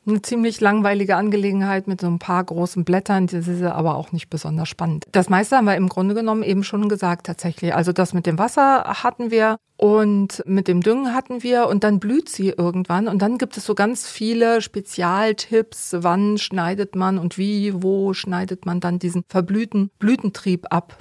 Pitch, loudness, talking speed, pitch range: 195 Hz, -20 LUFS, 190 wpm, 180-215 Hz